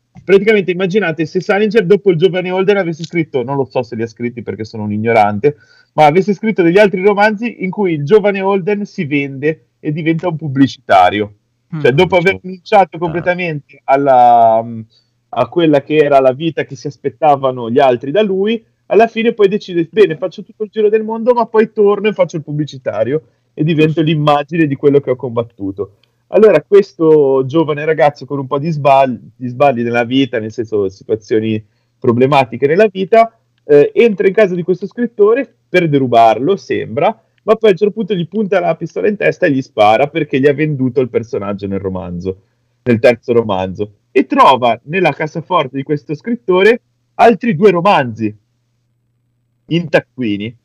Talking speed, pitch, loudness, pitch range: 175 wpm, 155 Hz, -13 LUFS, 120-195 Hz